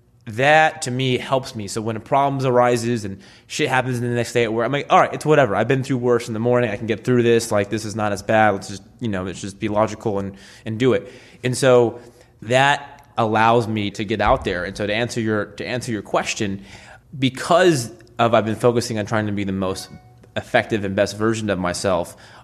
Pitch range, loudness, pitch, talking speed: 105-125 Hz, -20 LUFS, 115 Hz, 240 wpm